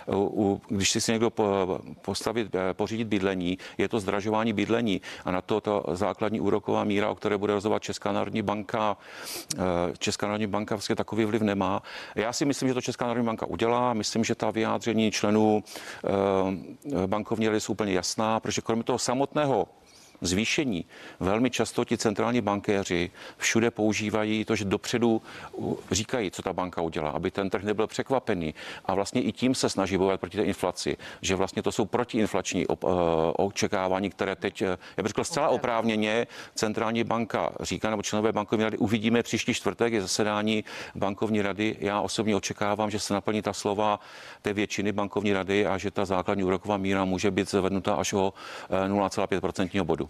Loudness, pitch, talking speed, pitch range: -27 LUFS, 105 Hz, 165 wpm, 95-110 Hz